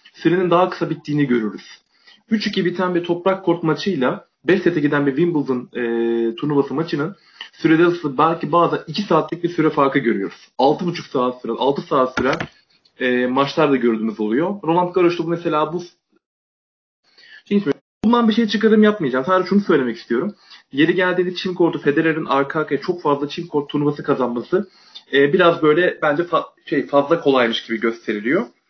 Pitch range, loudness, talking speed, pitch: 140-180 Hz, -19 LUFS, 160 wpm, 160 Hz